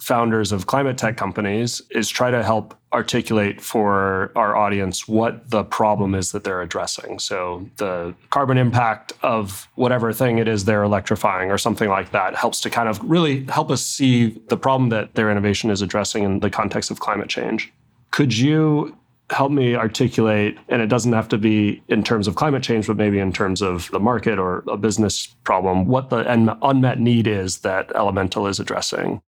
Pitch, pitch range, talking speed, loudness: 110 Hz, 105-120 Hz, 190 wpm, -20 LUFS